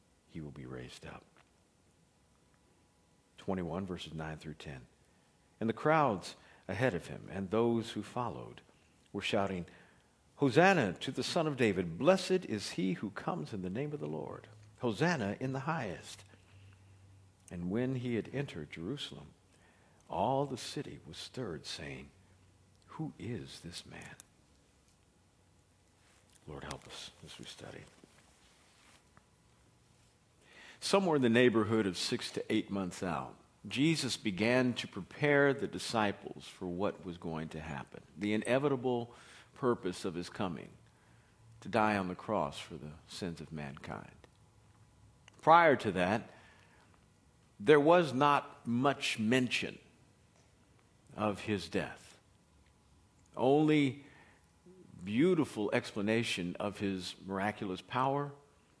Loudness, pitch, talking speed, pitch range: -34 LUFS, 105 Hz, 125 wpm, 90-130 Hz